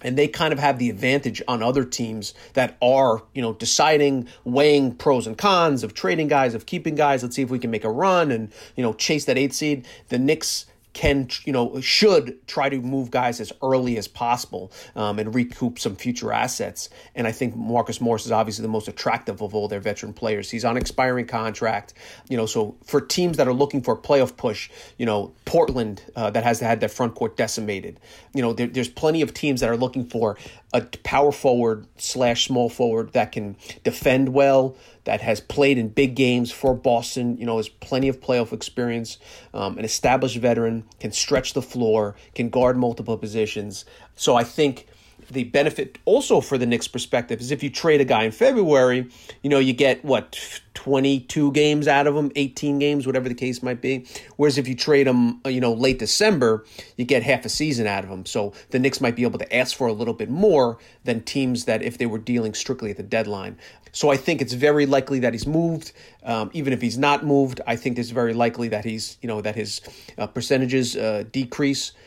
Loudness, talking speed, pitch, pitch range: -22 LUFS, 215 wpm, 125 Hz, 115-135 Hz